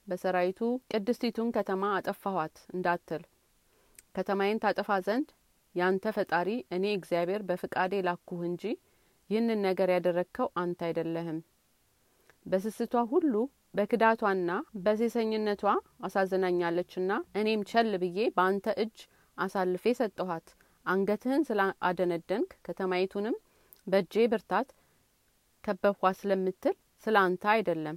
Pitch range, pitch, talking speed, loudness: 180-215 Hz, 195 Hz, 90 wpm, -31 LUFS